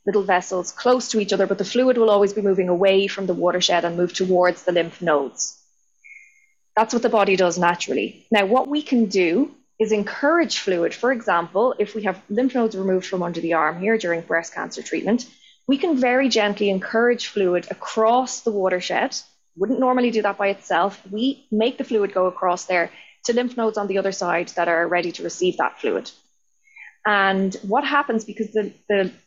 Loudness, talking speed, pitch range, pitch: -21 LUFS, 195 wpm, 185-240 Hz, 205 Hz